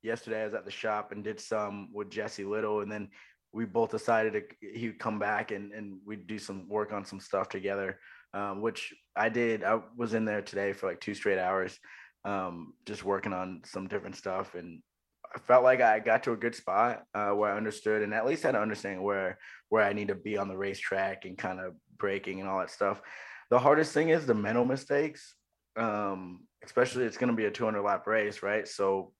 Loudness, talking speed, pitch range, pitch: -31 LUFS, 225 wpm, 100-115 Hz, 105 Hz